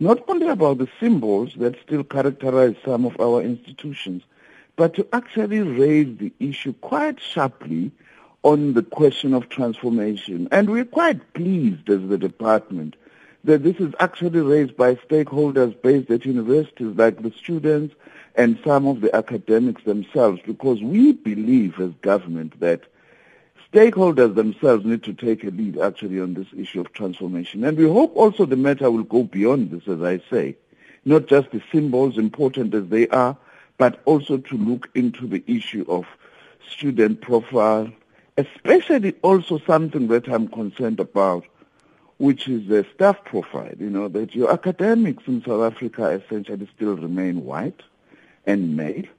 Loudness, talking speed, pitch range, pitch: -20 LUFS, 155 wpm, 110-160 Hz, 125 Hz